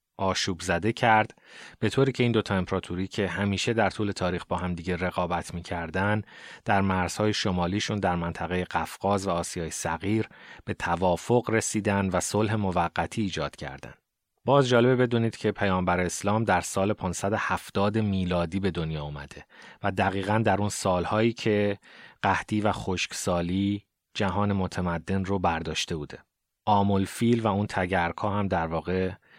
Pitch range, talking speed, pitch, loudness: 90-105 Hz, 145 wpm, 95 Hz, -27 LUFS